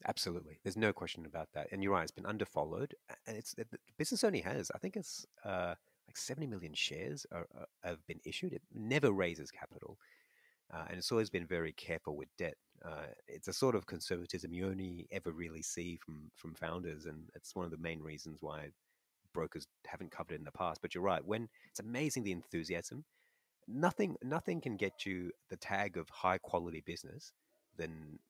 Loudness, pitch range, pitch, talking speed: -41 LUFS, 80-95 Hz, 85 Hz, 200 wpm